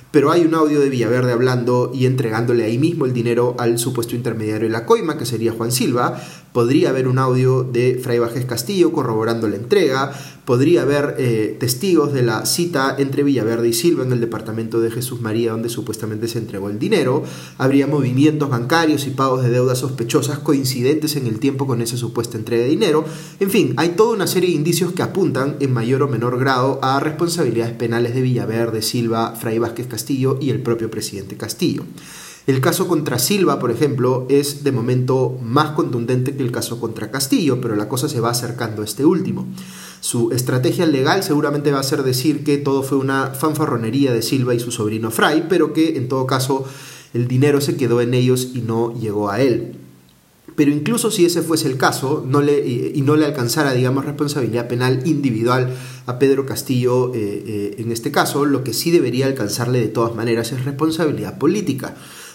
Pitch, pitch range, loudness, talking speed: 125 Hz, 115-145 Hz, -18 LUFS, 190 wpm